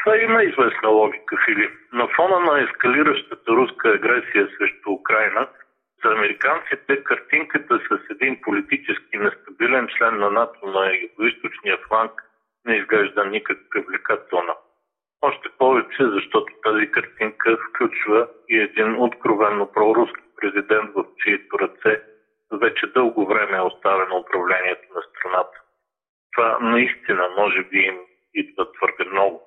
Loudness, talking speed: -20 LUFS, 120 wpm